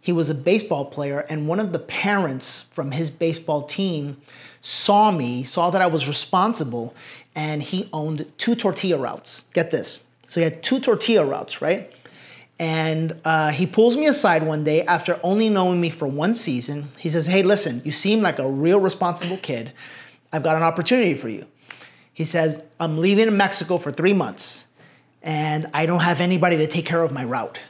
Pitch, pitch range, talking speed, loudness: 165 Hz, 155-190 Hz, 190 wpm, -21 LUFS